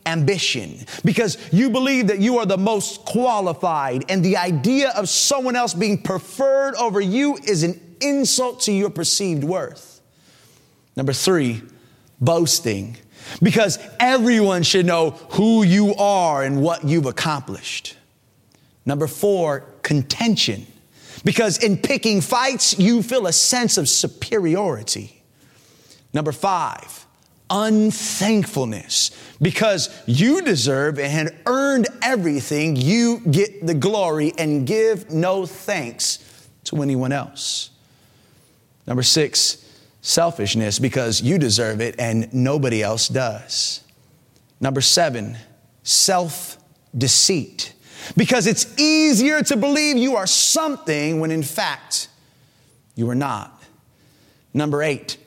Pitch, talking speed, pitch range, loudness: 165 Hz, 115 wpm, 135-210 Hz, -19 LUFS